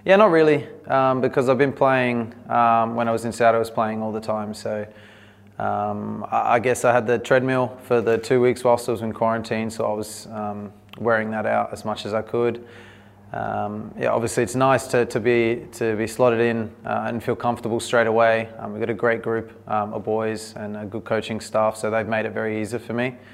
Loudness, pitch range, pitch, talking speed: -22 LUFS, 110-120 Hz, 115 Hz, 230 wpm